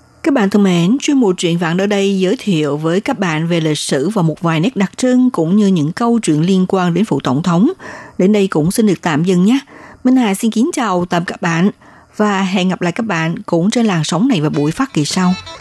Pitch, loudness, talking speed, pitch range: 185 Hz, -14 LUFS, 260 wpm, 165-210 Hz